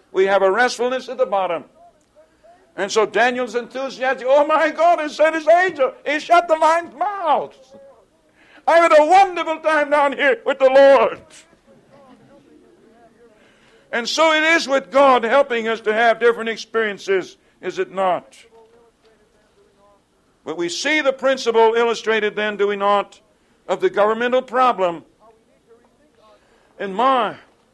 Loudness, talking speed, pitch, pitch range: -17 LUFS, 140 wpm, 245 Hz, 215-300 Hz